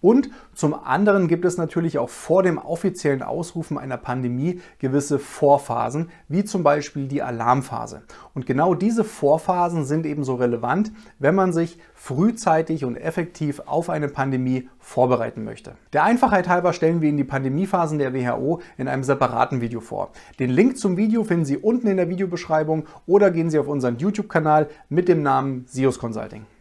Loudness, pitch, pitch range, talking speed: -22 LUFS, 155 Hz, 135-180 Hz, 165 wpm